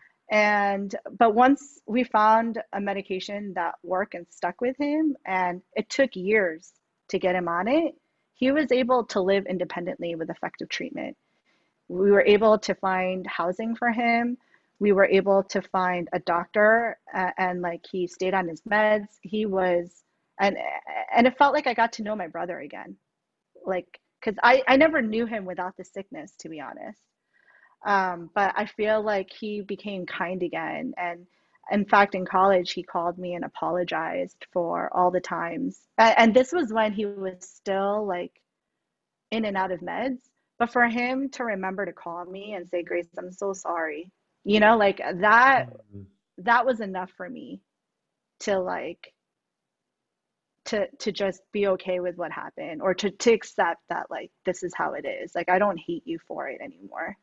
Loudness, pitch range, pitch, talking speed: -25 LUFS, 180-230 Hz, 200 Hz, 180 wpm